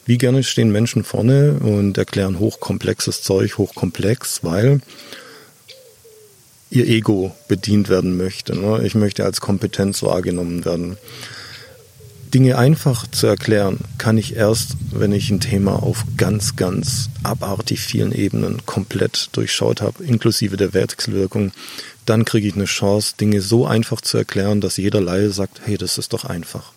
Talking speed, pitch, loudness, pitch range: 145 wpm, 105 Hz, -18 LUFS, 100-120 Hz